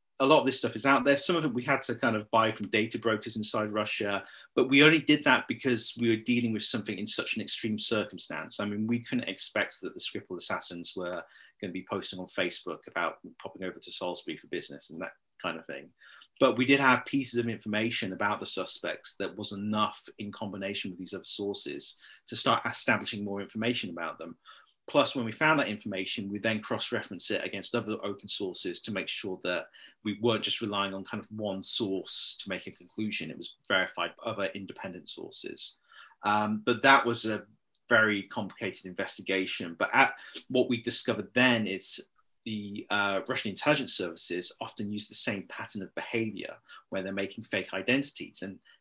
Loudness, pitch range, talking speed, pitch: -28 LUFS, 100-120 Hz, 200 wpm, 110 Hz